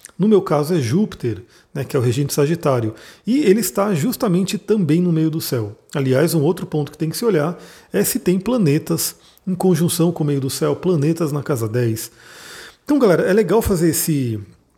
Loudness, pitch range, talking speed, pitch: -18 LUFS, 145-190 Hz, 205 wpm, 160 Hz